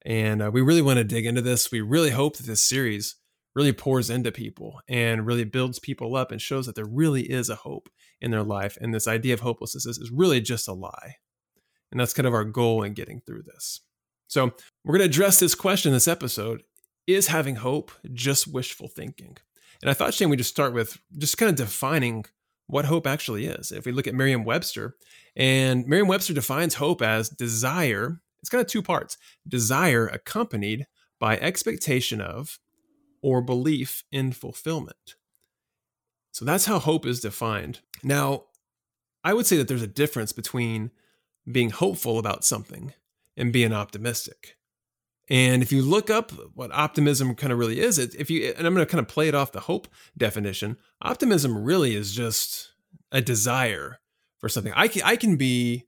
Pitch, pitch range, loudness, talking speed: 130 Hz, 115-155 Hz, -24 LUFS, 185 wpm